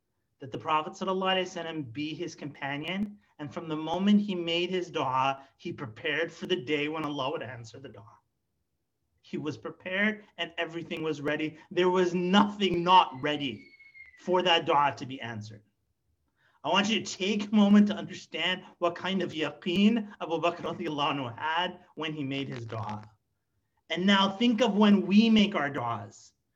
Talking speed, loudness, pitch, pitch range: 165 wpm, -28 LUFS, 165 Hz, 140-185 Hz